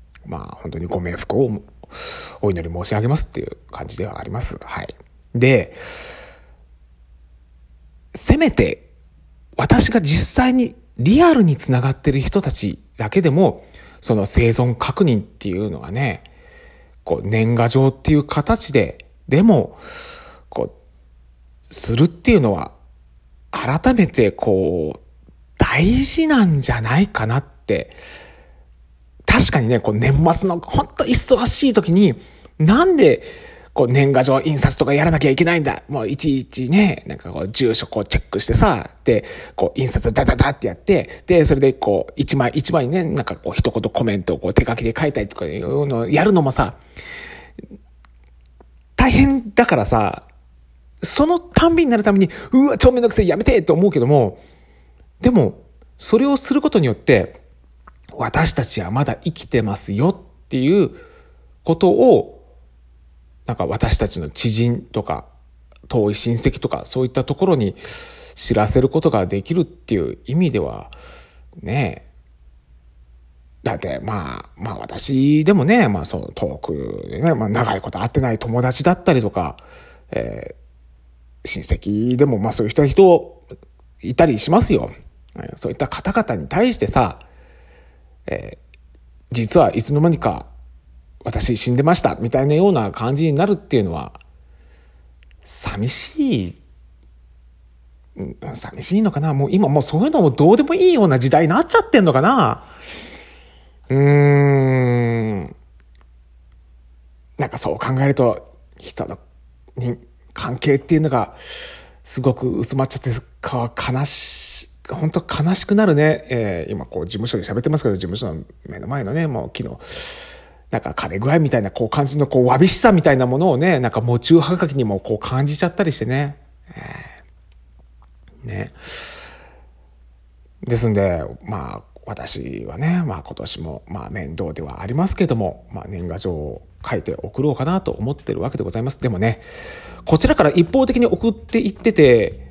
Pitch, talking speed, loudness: 120 Hz, 290 characters per minute, -17 LUFS